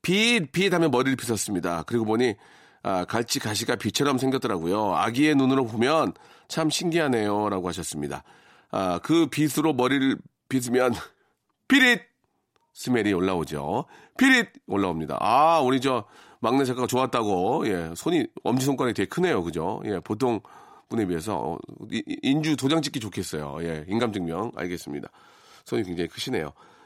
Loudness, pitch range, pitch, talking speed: -25 LUFS, 105-155 Hz, 130 Hz, 330 characters per minute